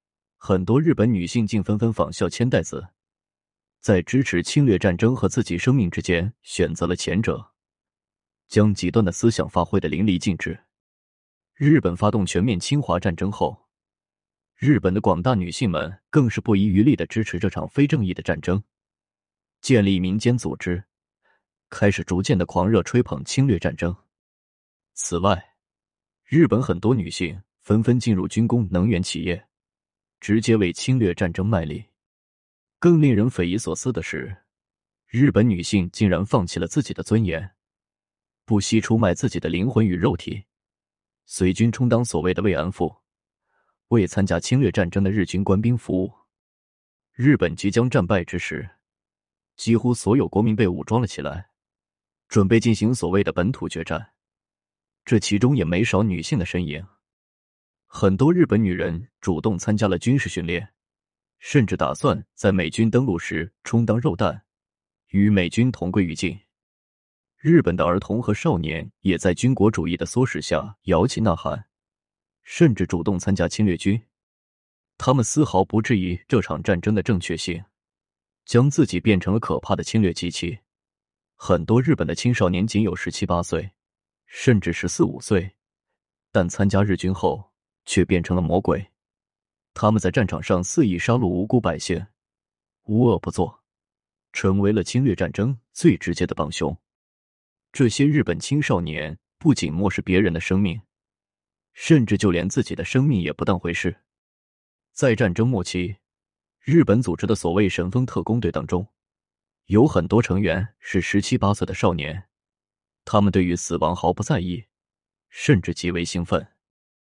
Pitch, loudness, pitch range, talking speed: 100 Hz, -21 LUFS, 85-110 Hz, 240 characters per minute